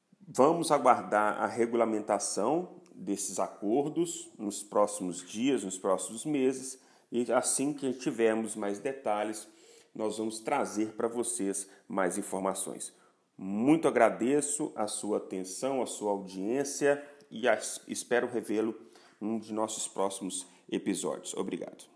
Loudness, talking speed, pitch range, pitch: -31 LUFS, 120 wpm, 100-130 Hz, 110 Hz